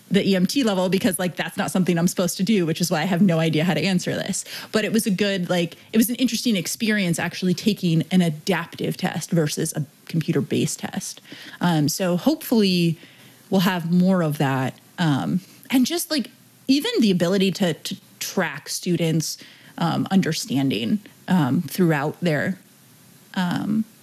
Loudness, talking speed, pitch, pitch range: -22 LUFS, 170 wpm, 185 Hz, 165-200 Hz